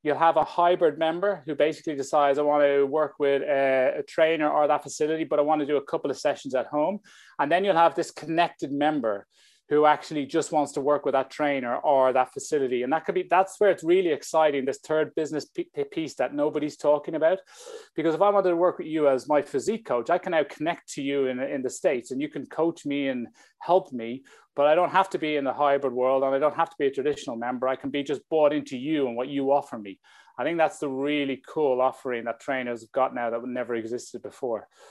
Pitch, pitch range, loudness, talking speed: 150 Hz, 135-165 Hz, -25 LUFS, 245 wpm